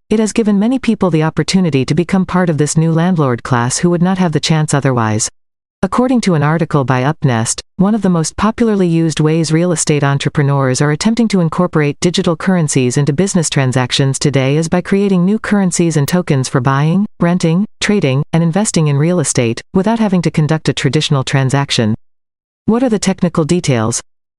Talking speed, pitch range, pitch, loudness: 185 wpm, 145-185 Hz, 165 Hz, -13 LUFS